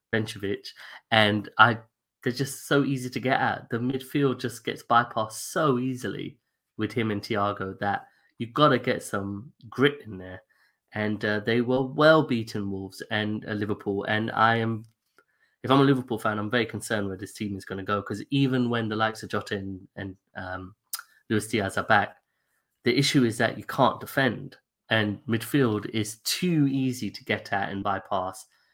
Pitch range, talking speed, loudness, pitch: 105-125 Hz, 180 wpm, -26 LUFS, 110 Hz